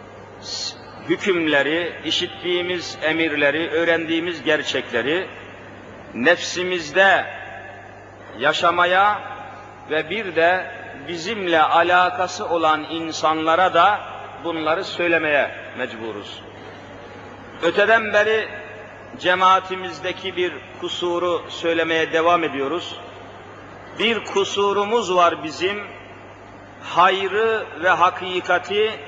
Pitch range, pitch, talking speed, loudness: 155-185 Hz, 175 Hz, 70 wpm, -20 LUFS